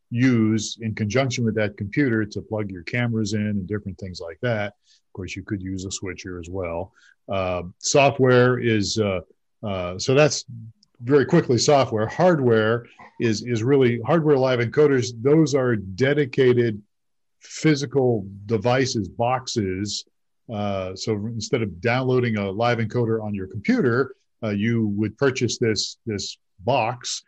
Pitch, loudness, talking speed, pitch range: 115 Hz, -22 LUFS, 145 wpm, 105-125 Hz